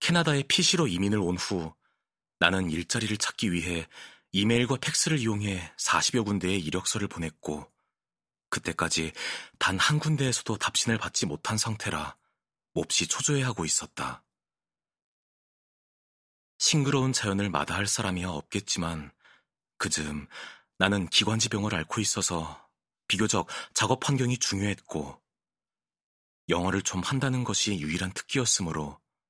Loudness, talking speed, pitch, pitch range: -27 LUFS, 275 characters per minute, 100 Hz, 85-120 Hz